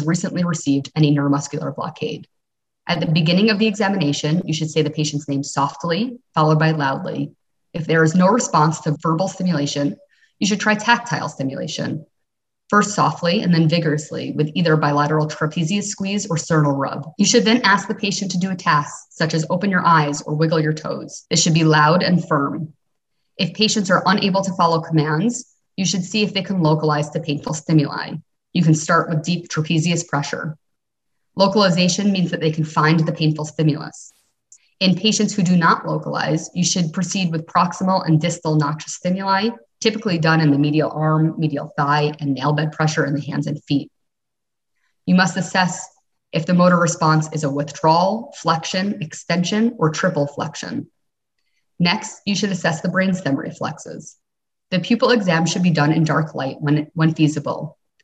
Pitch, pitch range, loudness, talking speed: 165 Hz, 150-185 Hz, -19 LUFS, 175 wpm